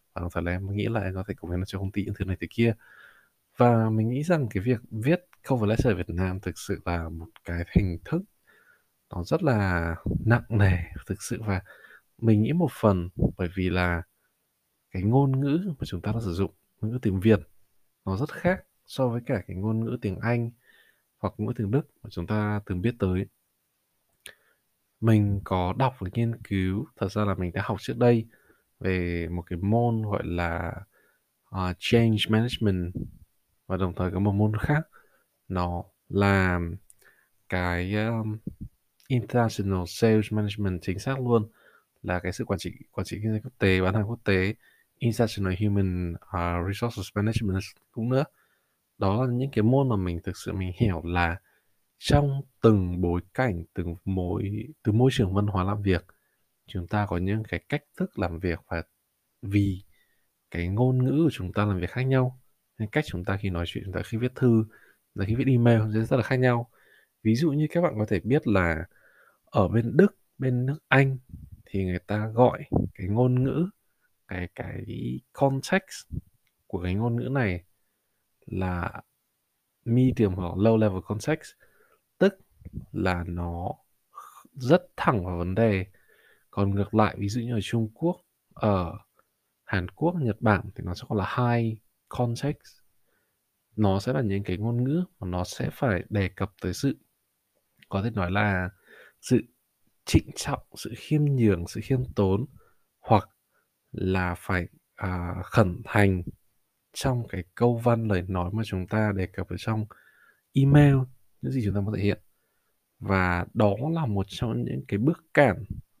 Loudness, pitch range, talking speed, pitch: -27 LUFS, 95-120 Hz, 180 wpm, 105 Hz